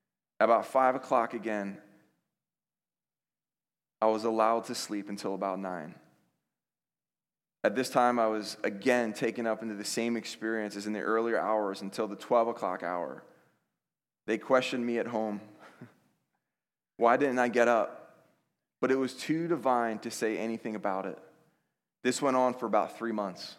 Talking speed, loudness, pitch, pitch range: 155 wpm, -30 LUFS, 115 Hz, 105-125 Hz